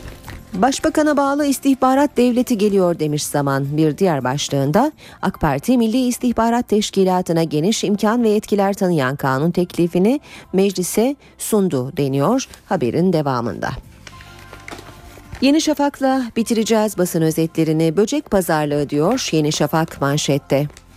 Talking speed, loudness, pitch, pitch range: 110 wpm, -18 LUFS, 180 Hz, 145-235 Hz